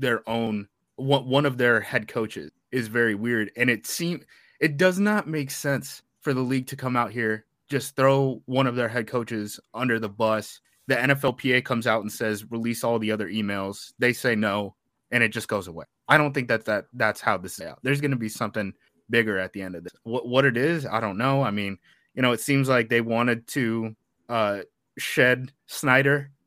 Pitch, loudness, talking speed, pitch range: 120 Hz, -25 LUFS, 215 wpm, 110-135 Hz